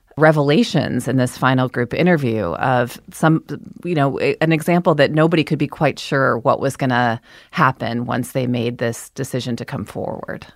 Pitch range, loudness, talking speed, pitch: 120-155 Hz, -18 LUFS, 175 wpm, 135 Hz